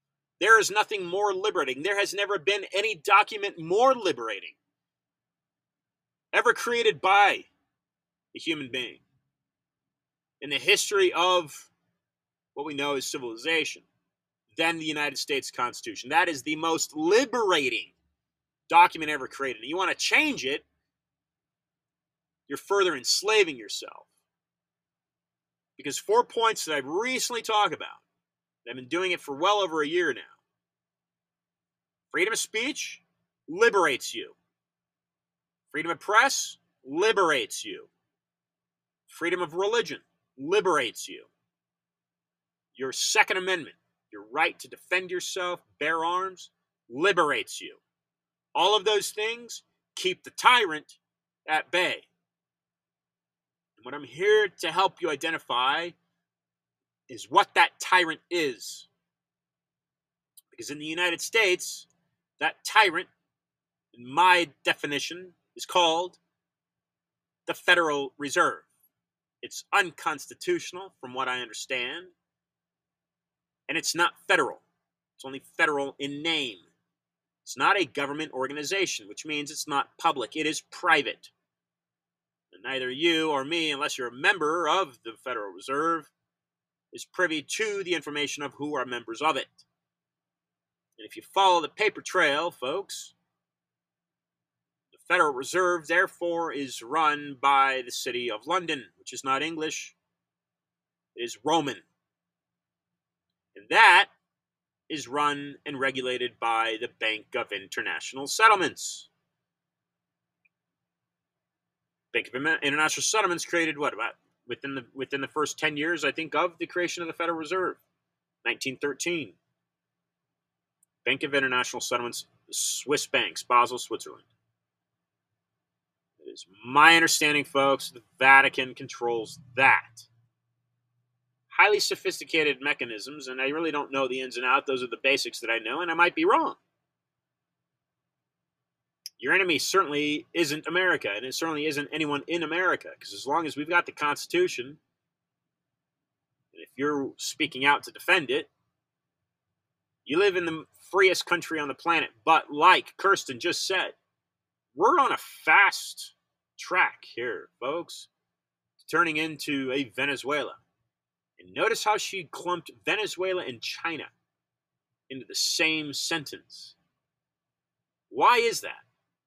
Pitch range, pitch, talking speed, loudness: 140-215 Hz, 165 Hz, 125 wpm, -25 LUFS